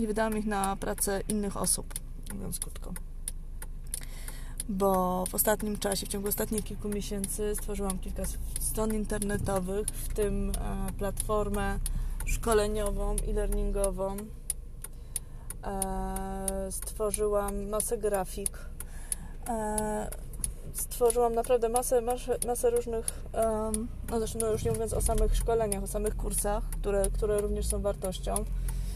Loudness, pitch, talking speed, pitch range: -31 LUFS, 205 Hz, 110 wpm, 195-215 Hz